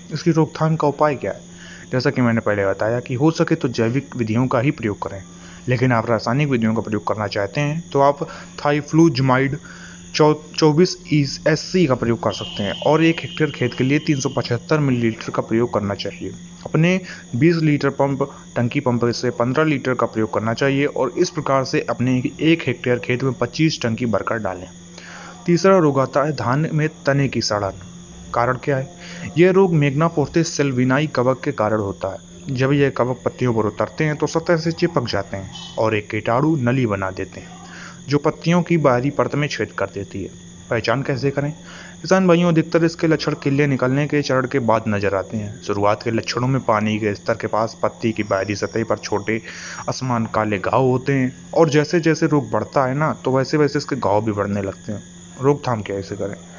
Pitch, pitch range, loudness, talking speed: 130 Hz, 110-150 Hz, -19 LUFS, 205 wpm